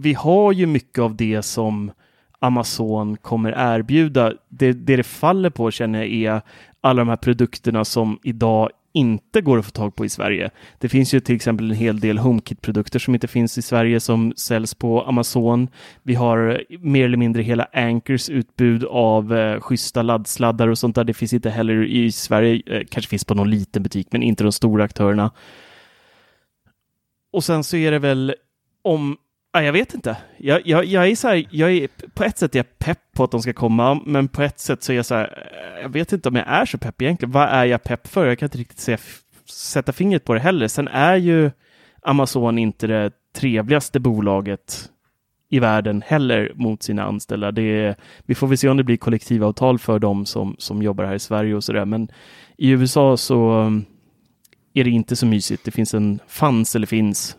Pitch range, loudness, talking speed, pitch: 110-135 Hz, -19 LUFS, 205 wpm, 120 Hz